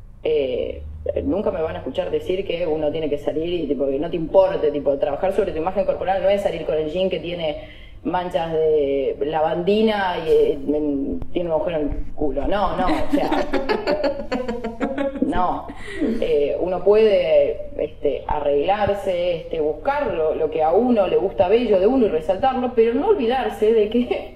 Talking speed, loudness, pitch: 175 wpm, -21 LUFS, 195 Hz